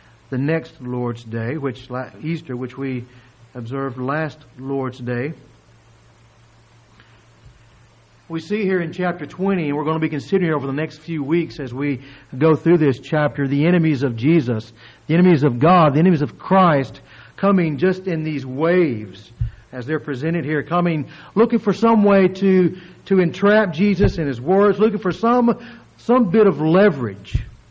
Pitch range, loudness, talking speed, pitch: 125-180 Hz, -19 LUFS, 160 wpm, 150 Hz